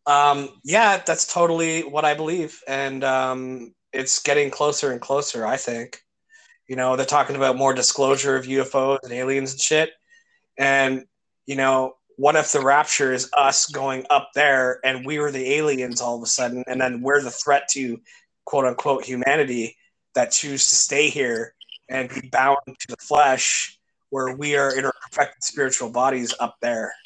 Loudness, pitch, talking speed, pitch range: -21 LUFS, 135 Hz, 175 wpm, 130-145 Hz